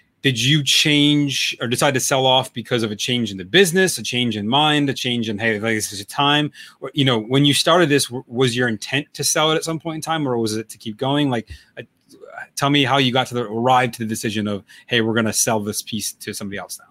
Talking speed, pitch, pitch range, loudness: 275 wpm, 125 Hz, 110-145 Hz, -18 LUFS